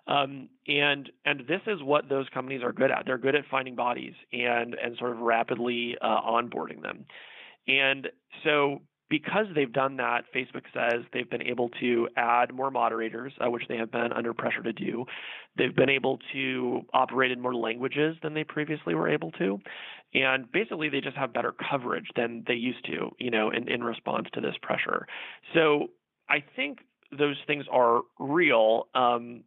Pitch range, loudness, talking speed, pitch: 120-145 Hz, -28 LUFS, 180 wpm, 130 Hz